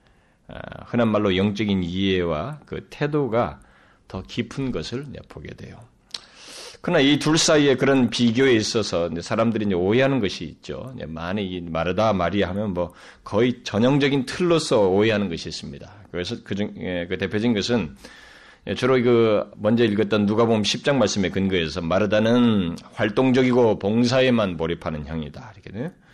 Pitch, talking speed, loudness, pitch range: 105 Hz, 315 characters per minute, -21 LUFS, 95-125 Hz